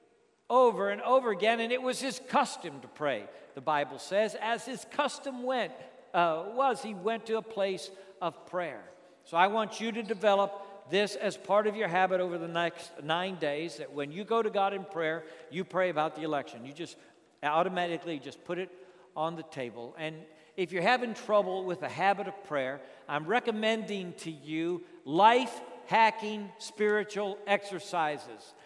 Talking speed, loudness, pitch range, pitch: 175 wpm, -31 LUFS, 170-225 Hz, 195 Hz